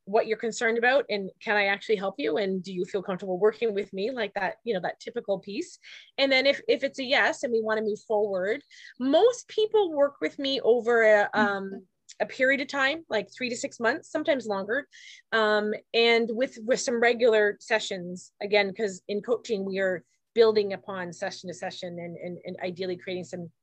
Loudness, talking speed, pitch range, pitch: -26 LUFS, 205 wpm, 195-250 Hz, 215 Hz